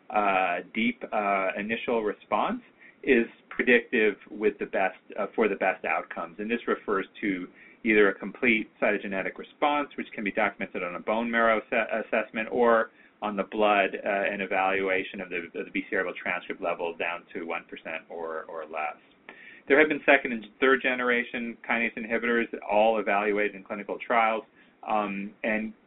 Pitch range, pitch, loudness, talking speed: 105-125 Hz, 110 Hz, -27 LUFS, 165 wpm